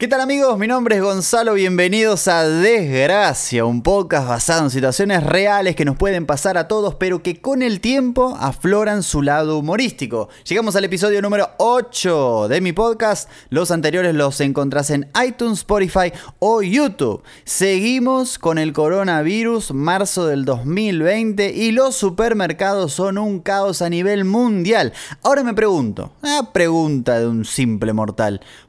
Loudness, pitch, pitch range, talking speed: -17 LUFS, 195 Hz, 155-220 Hz, 155 wpm